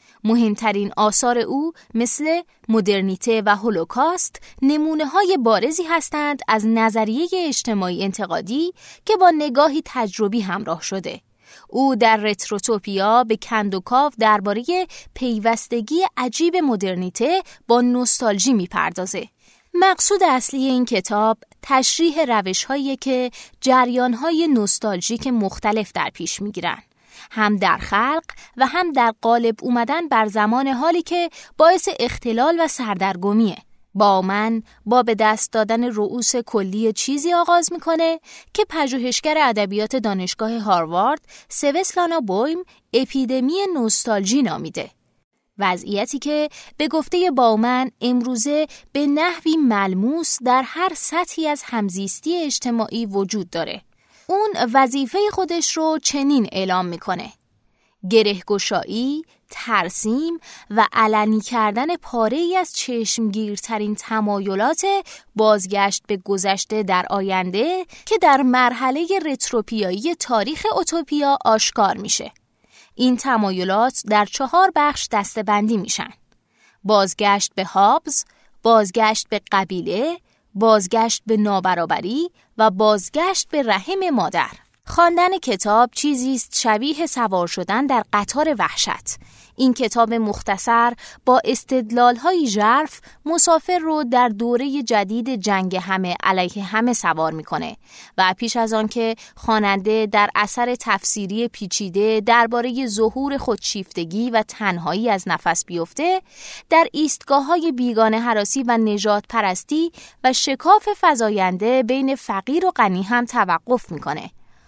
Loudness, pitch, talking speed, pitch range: -19 LUFS, 235 Hz, 110 wpm, 210-295 Hz